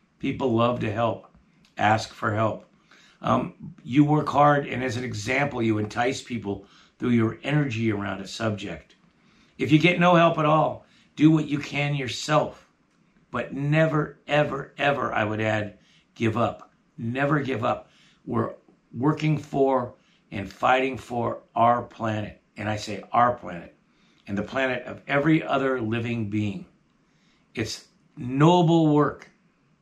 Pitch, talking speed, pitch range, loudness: 130 Hz, 145 wpm, 110-150 Hz, -24 LUFS